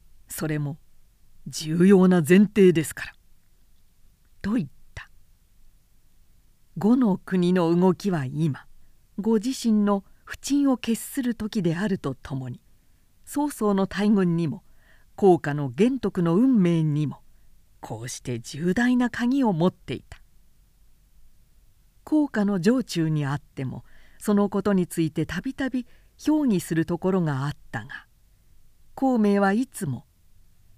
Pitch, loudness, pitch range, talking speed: 175 Hz, -24 LUFS, 135-210 Hz, 220 characters per minute